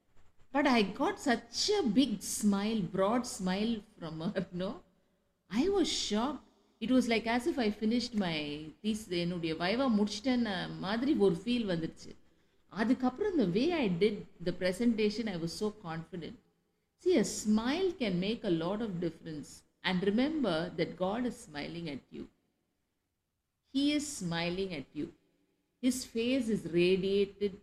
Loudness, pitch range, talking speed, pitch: -33 LUFS, 180-245 Hz, 130 wpm, 210 Hz